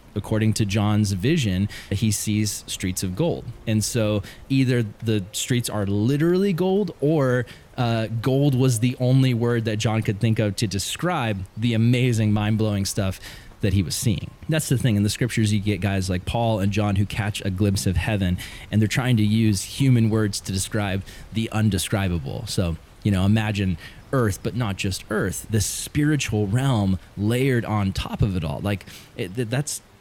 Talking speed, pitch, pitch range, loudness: 180 wpm, 110 Hz, 100-120 Hz, -23 LUFS